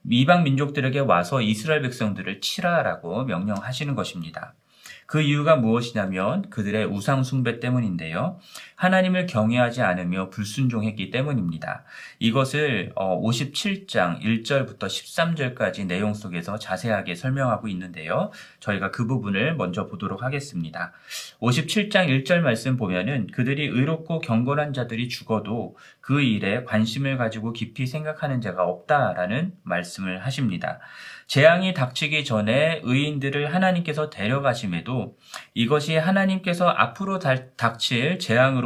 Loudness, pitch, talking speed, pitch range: -24 LUFS, 125 Hz, 320 characters per minute, 105-150 Hz